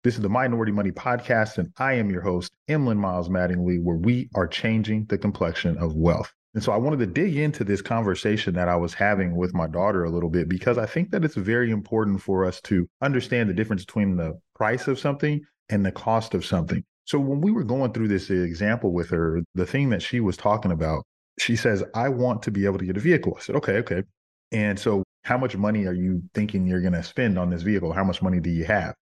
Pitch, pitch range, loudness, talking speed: 100 Hz, 90-120 Hz, -24 LUFS, 240 wpm